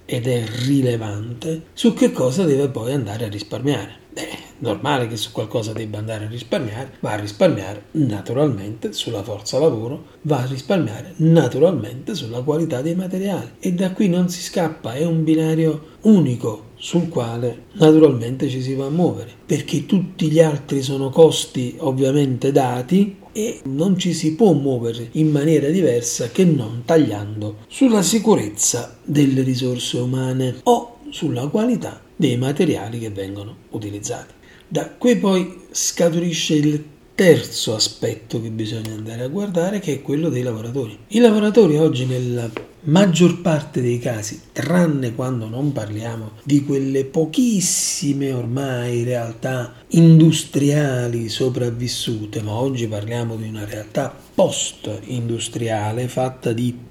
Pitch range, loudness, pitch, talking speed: 120-160 Hz, -19 LUFS, 135 Hz, 140 wpm